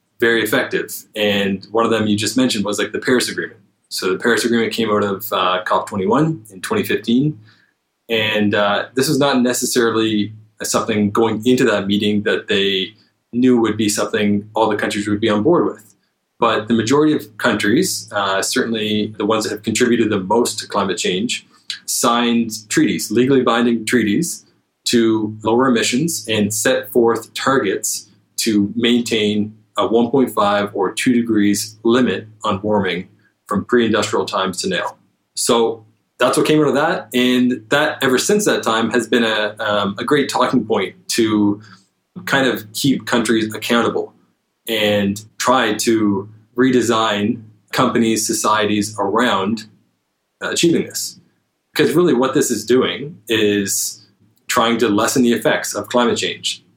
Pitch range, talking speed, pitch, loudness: 105-120 Hz, 155 wpm, 110 Hz, -17 LUFS